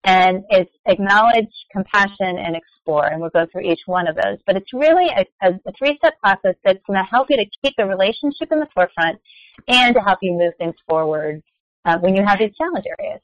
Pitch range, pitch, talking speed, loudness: 180-250 Hz, 195 Hz, 215 wpm, -17 LUFS